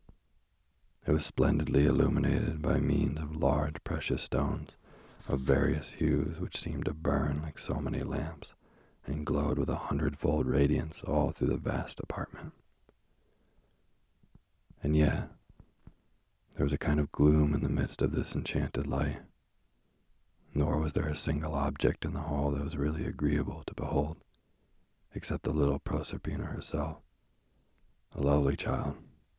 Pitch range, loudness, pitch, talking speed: 70-75 Hz, -32 LUFS, 75 Hz, 145 wpm